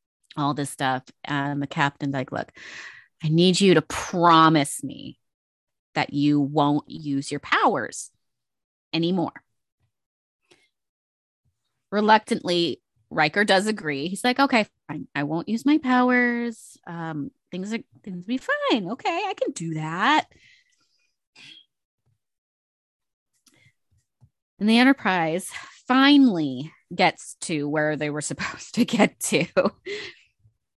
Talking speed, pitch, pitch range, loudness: 115 wpm, 165 Hz, 145-230 Hz, -23 LUFS